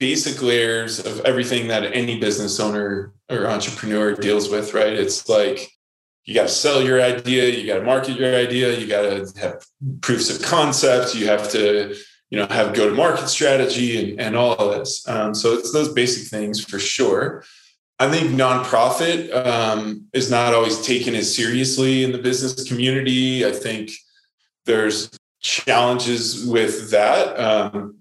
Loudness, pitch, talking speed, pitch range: -19 LUFS, 120 Hz, 160 wpm, 105-130 Hz